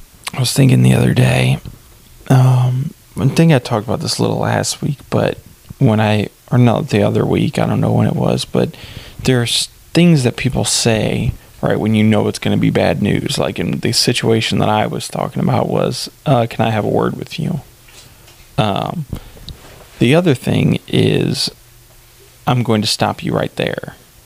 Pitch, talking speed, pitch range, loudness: 120 Hz, 195 wpm, 110-130 Hz, -15 LUFS